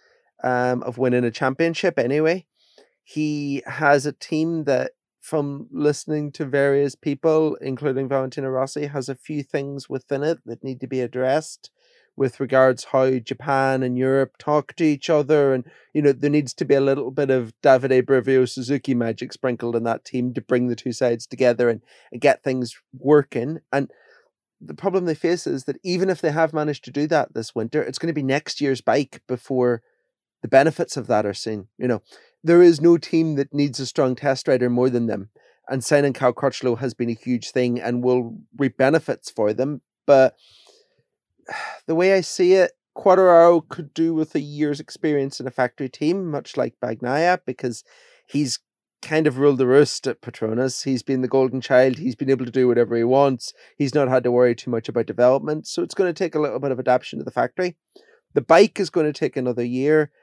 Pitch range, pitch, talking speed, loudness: 125-155 Hz, 135 Hz, 200 wpm, -21 LUFS